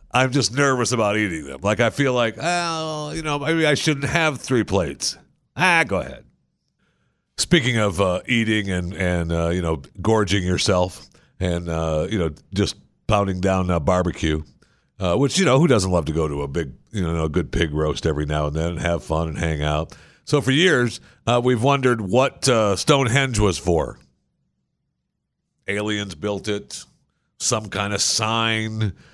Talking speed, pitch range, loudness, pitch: 180 wpm, 85-125 Hz, -21 LUFS, 105 Hz